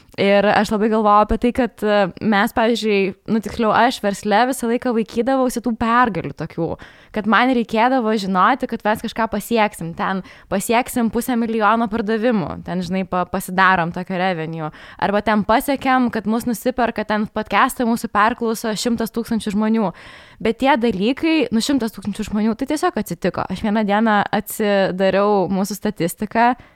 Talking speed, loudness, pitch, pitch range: 150 wpm, -19 LUFS, 220 Hz, 200-235 Hz